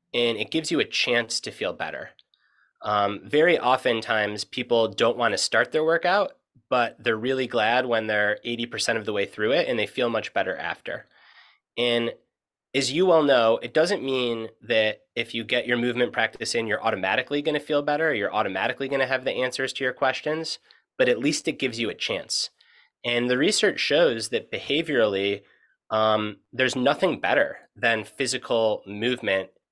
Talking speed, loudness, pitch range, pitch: 185 wpm, -24 LUFS, 110-135 Hz, 120 Hz